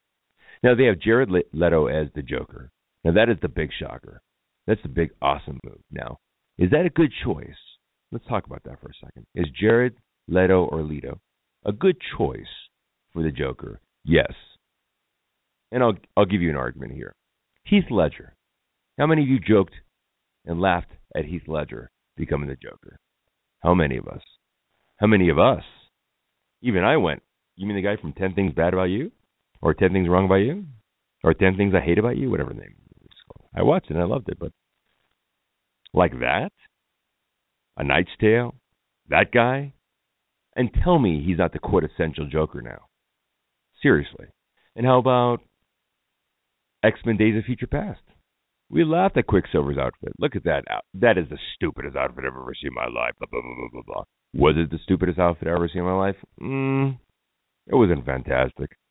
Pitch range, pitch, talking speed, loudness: 75-110 Hz, 90 Hz, 185 wpm, -22 LUFS